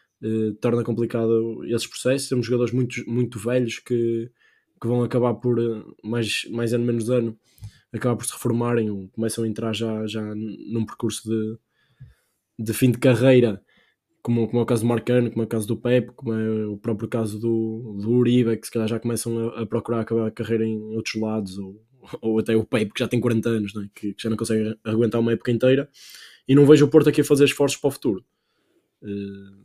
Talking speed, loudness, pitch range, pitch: 215 wpm, -23 LUFS, 110-120 Hz, 115 Hz